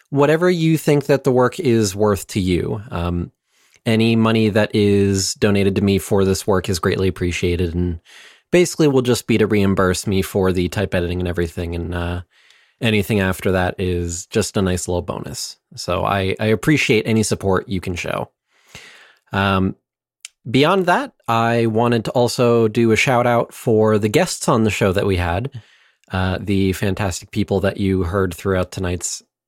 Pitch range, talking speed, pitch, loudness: 95-115 Hz, 175 wpm, 100 Hz, -18 LUFS